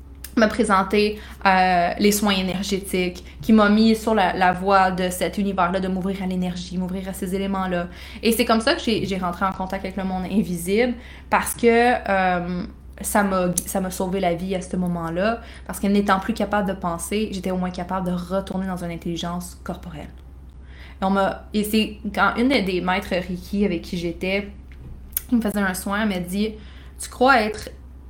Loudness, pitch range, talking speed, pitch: -22 LUFS, 180-205 Hz, 195 wpm, 190 Hz